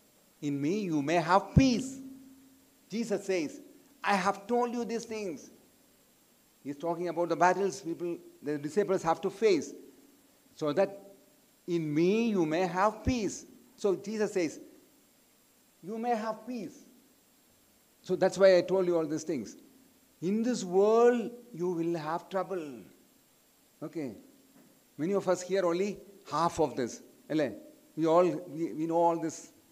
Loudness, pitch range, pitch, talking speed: -30 LUFS, 175-265 Hz, 200 Hz, 145 wpm